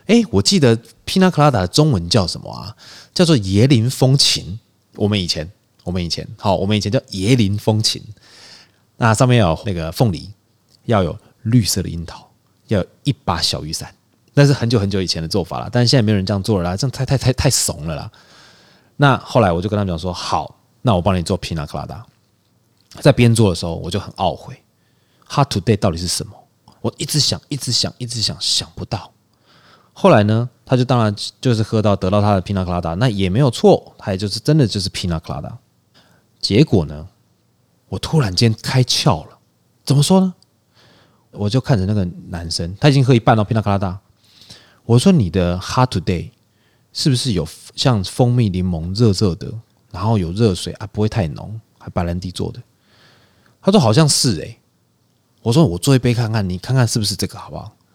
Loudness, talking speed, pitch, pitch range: -17 LUFS, 300 characters per minute, 110 Hz, 95-125 Hz